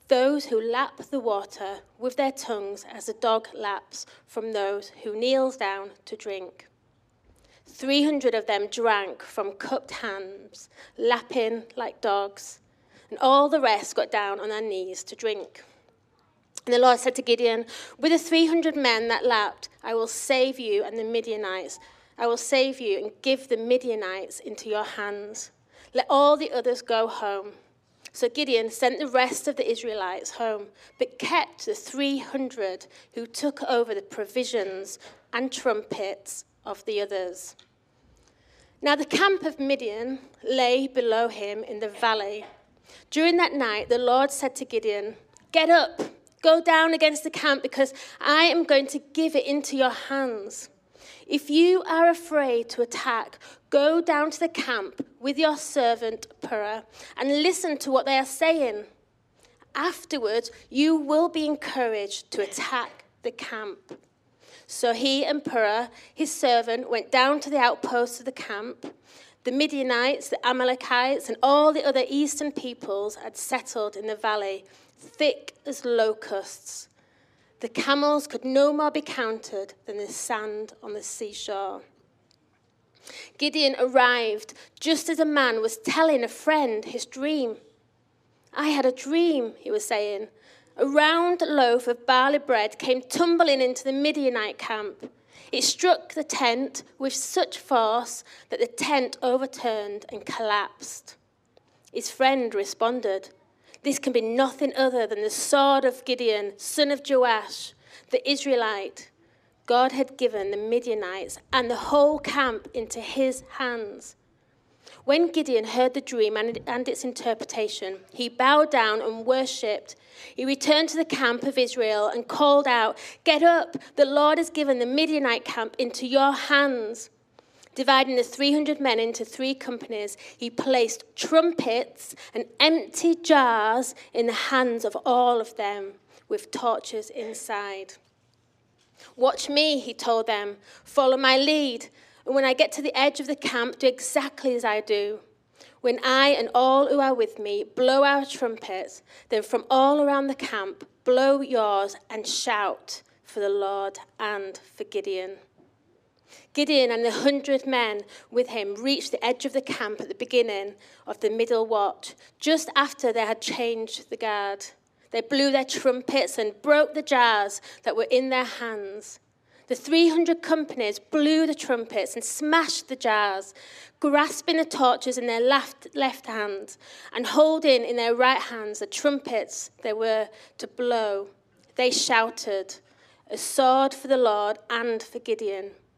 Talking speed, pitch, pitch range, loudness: 155 wpm, 255 Hz, 225-290 Hz, -24 LUFS